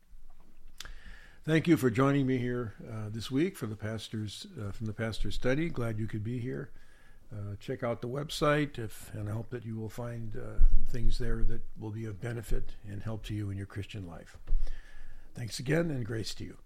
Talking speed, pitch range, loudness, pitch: 205 wpm, 105-125 Hz, -34 LUFS, 115 Hz